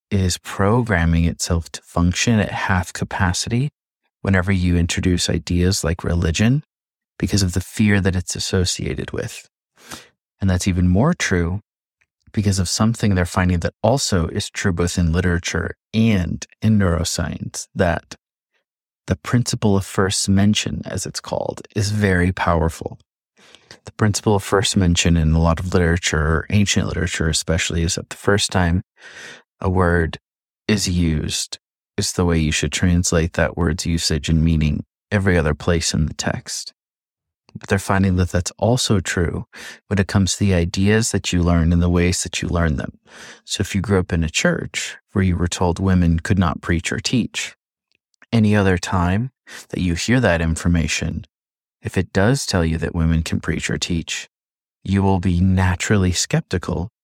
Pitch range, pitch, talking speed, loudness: 85-100 Hz, 90 Hz, 165 wpm, -19 LUFS